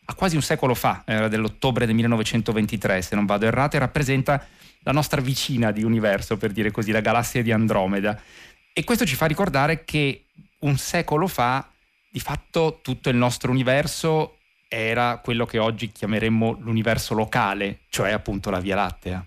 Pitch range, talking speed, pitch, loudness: 110-140 Hz, 165 wpm, 120 Hz, -23 LUFS